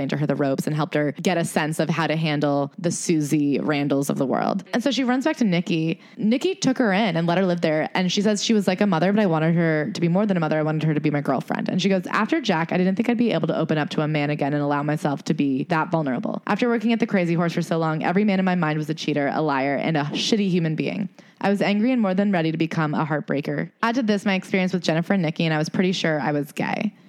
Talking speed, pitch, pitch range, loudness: 305 wpm, 170 Hz, 155-205 Hz, -22 LUFS